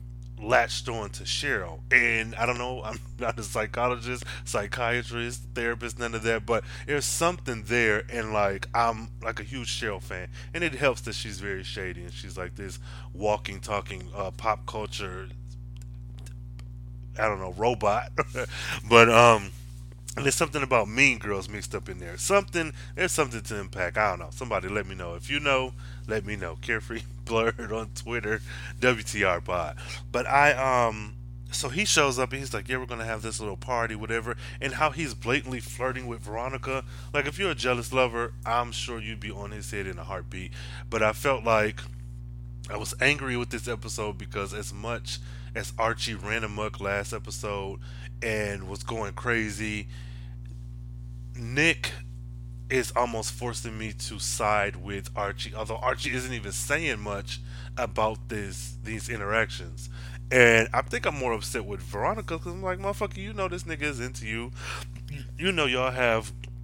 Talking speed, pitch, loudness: 170 wpm, 115 Hz, -28 LUFS